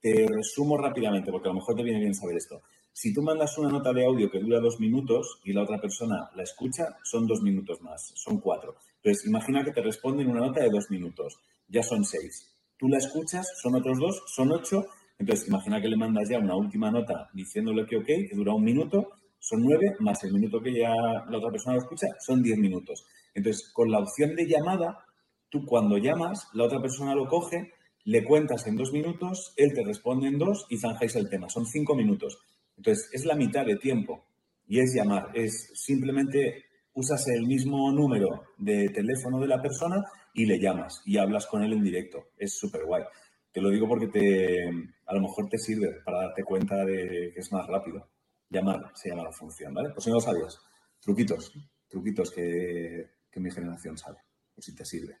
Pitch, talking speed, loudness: 135 Hz, 205 wpm, -28 LUFS